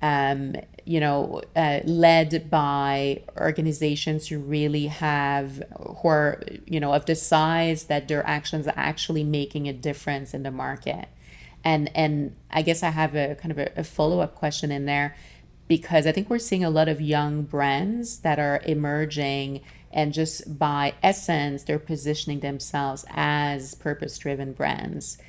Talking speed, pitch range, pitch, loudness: 155 wpm, 140-160 Hz, 150 Hz, -24 LUFS